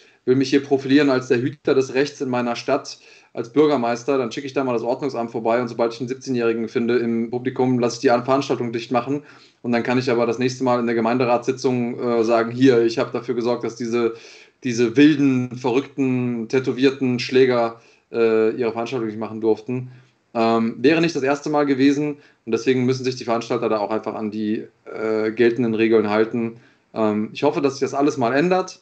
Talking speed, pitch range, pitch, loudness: 205 wpm, 115-135 Hz, 125 Hz, -20 LUFS